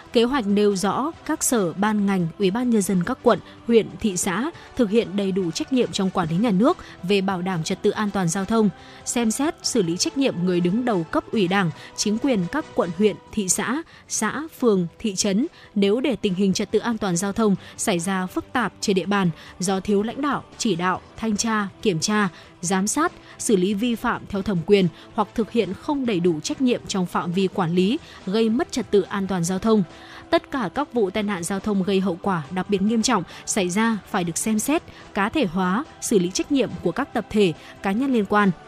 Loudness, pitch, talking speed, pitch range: -23 LUFS, 205 Hz, 235 wpm, 190-235 Hz